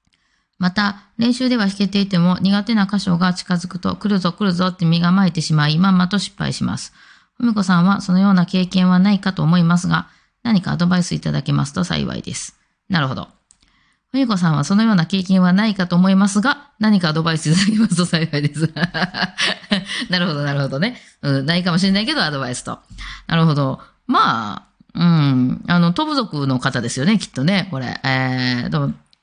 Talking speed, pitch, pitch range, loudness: 385 characters per minute, 180 Hz, 160-200 Hz, -18 LUFS